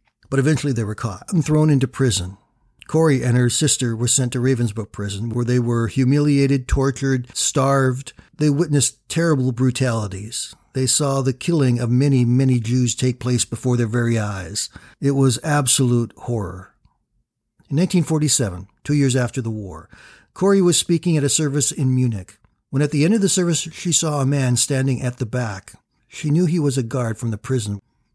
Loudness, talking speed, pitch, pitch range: -19 LUFS, 180 wpm, 130 Hz, 120-145 Hz